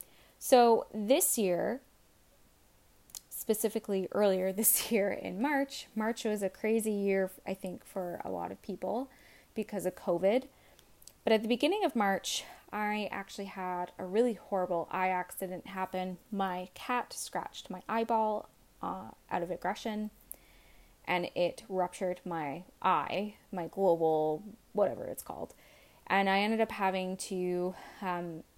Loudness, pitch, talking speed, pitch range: -33 LUFS, 195 Hz, 135 wpm, 185-225 Hz